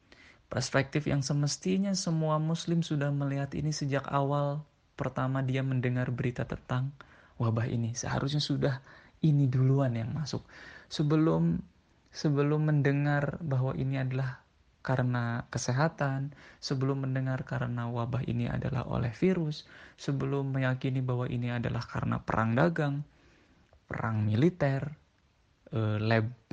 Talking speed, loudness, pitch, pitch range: 115 wpm, -31 LUFS, 135 Hz, 125-145 Hz